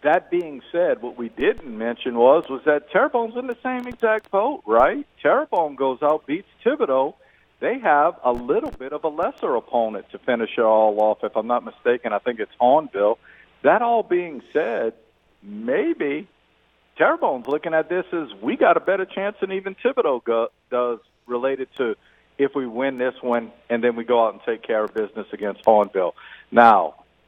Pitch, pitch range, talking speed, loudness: 140 Hz, 120-200 Hz, 185 wpm, -21 LUFS